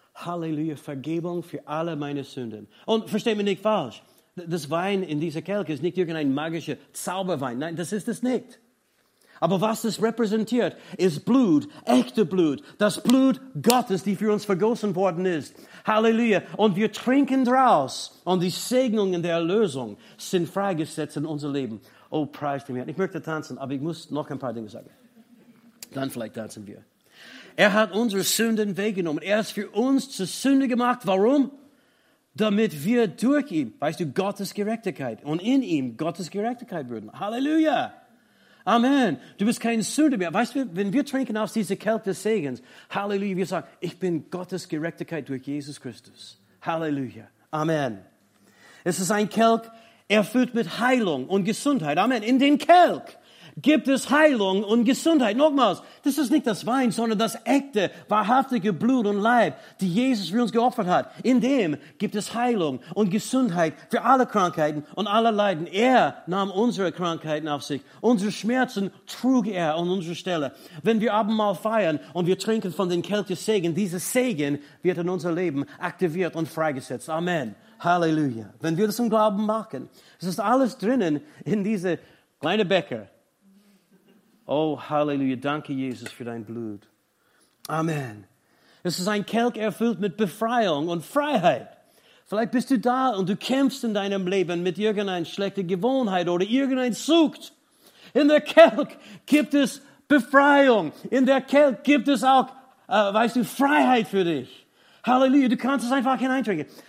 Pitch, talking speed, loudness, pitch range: 205 Hz, 165 wpm, -24 LUFS, 165-240 Hz